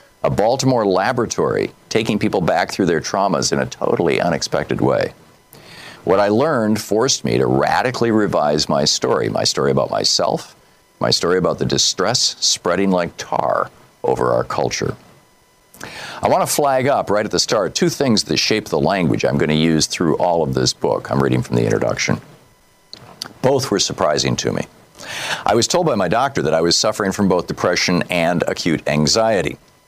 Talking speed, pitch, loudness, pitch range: 180 wpm, 90 Hz, -17 LUFS, 75-110 Hz